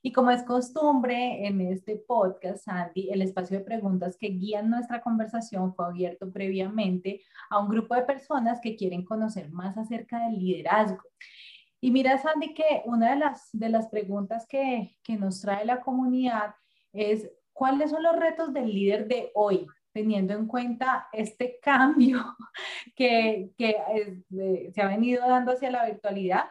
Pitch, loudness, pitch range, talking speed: 220 Hz, -27 LUFS, 200-250 Hz, 160 wpm